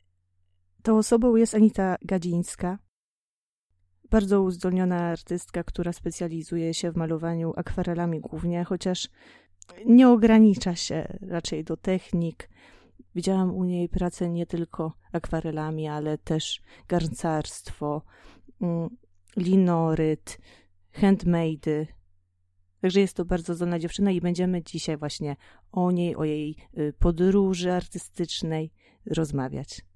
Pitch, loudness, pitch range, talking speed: 170 Hz, -26 LUFS, 155-185 Hz, 100 wpm